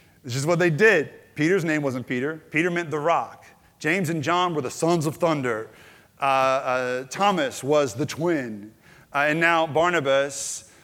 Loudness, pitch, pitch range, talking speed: -23 LUFS, 155 Hz, 135-170 Hz, 170 wpm